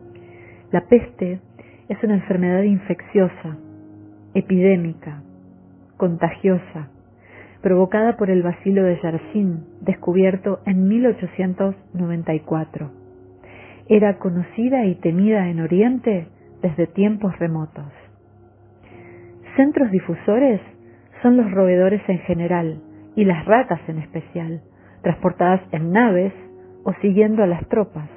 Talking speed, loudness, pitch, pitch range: 100 wpm, -19 LUFS, 175 Hz, 145-195 Hz